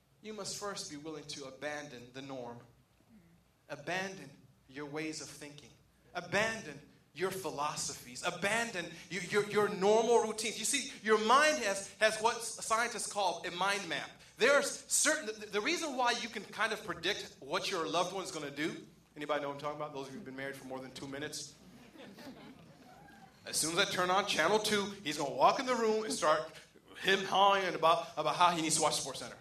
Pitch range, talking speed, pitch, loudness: 150-210 Hz, 195 wpm, 175 Hz, -33 LUFS